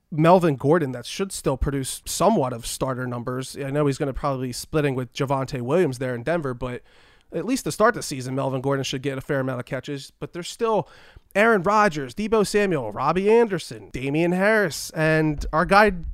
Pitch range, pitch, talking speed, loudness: 130-180 Hz, 145 Hz, 205 wpm, -23 LUFS